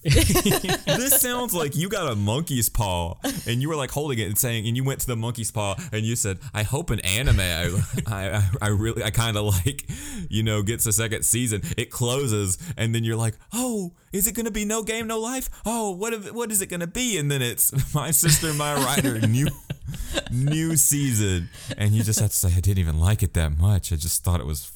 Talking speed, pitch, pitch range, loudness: 235 wpm, 115 Hz, 105-155 Hz, -23 LUFS